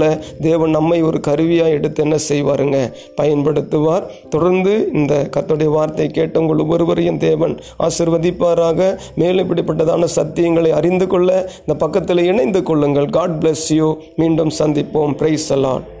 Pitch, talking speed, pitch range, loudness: 160 Hz, 105 wpm, 155-170 Hz, -15 LUFS